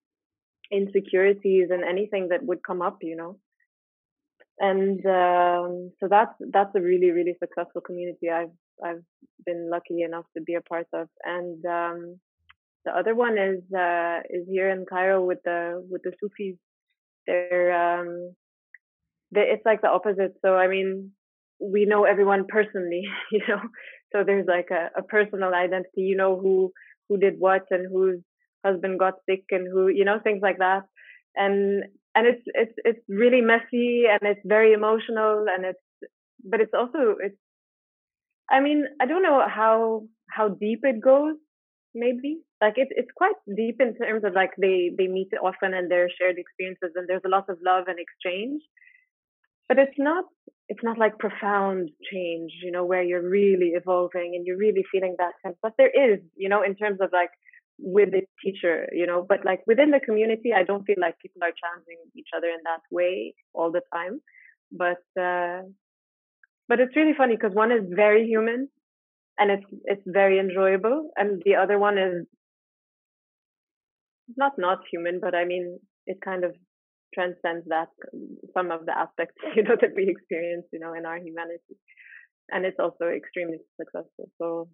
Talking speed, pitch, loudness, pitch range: 175 wpm, 190 Hz, -24 LUFS, 180-220 Hz